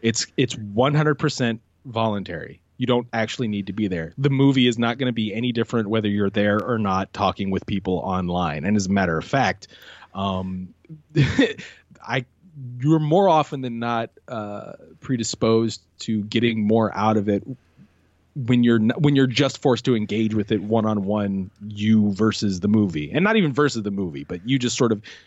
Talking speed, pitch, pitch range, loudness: 185 wpm, 110 Hz, 100-130 Hz, -22 LUFS